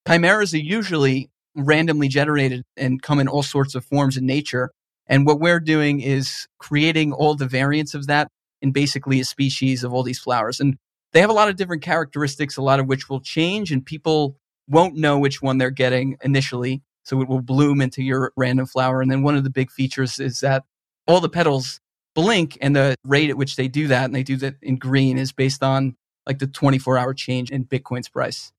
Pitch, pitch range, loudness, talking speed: 135 Hz, 130-150 Hz, -20 LUFS, 215 wpm